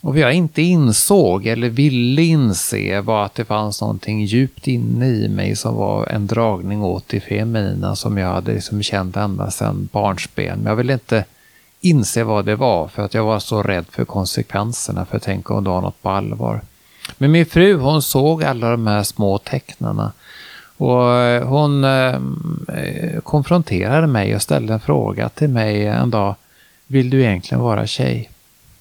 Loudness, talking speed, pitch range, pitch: -17 LUFS, 175 wpm, 100-135 Hz, 110 Hz